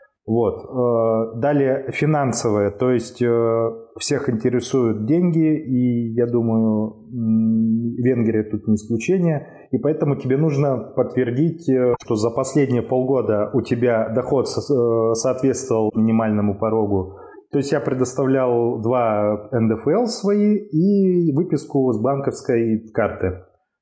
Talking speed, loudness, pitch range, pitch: 105 wpm, -20 LUFS, 115-140 Hz, 120 Hz